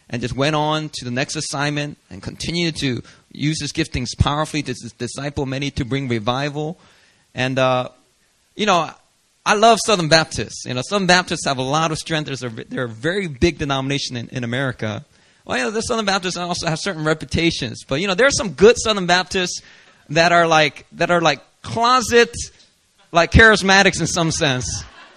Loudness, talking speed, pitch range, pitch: -18 LUFS, 185 wpm, 130-175 Hz, 155 Hz